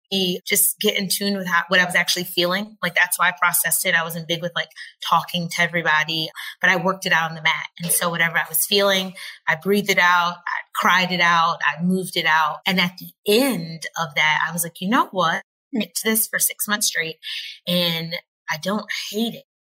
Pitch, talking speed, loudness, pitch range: 175 Hz, 230 wpm, -20 LUFS, 165-195 Hz